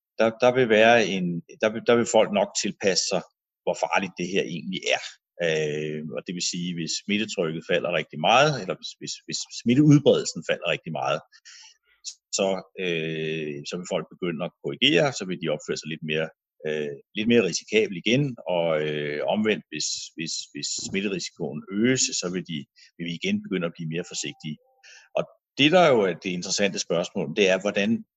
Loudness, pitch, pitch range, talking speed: -24 LUFS, 95 Hz, 80-120 Hz, 180 wpm